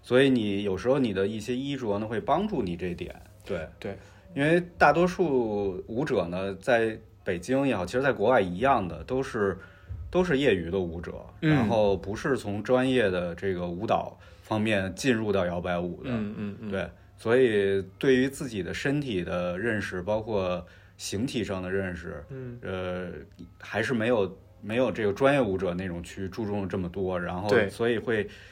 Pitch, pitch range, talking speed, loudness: 100 Hz, 95-125 Hz, 255 characters per minute, -27 LUFS